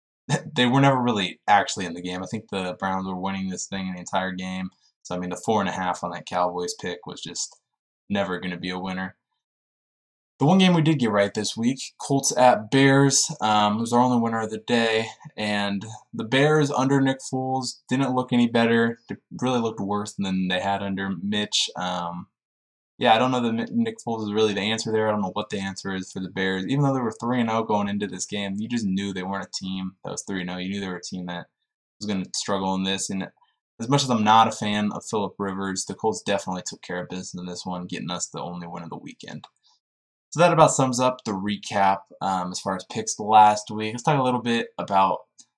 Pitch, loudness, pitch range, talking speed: 105 Hz, -24 LUFS, 95-120 Hz, 250 wpm